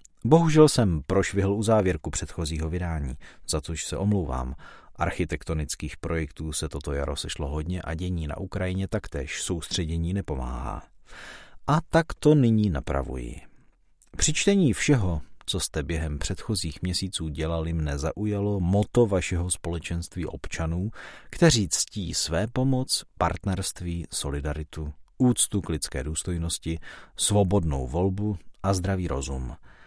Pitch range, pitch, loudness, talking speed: 75-100 Hz, 85 Hz, -26 LUFS, 120 wpm